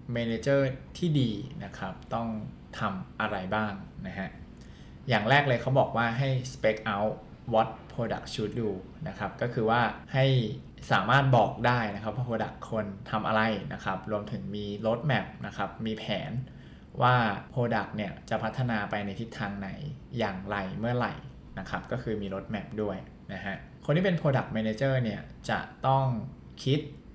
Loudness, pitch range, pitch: -30 LUFS, 105-130 Hz, 115 Hz